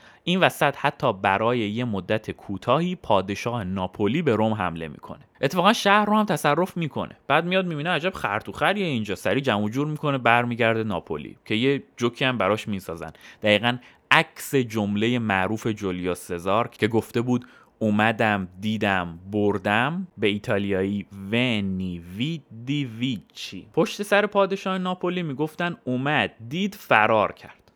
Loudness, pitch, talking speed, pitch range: -24 LUFS, 115 Hz, 135 wpm, 100-150 Hz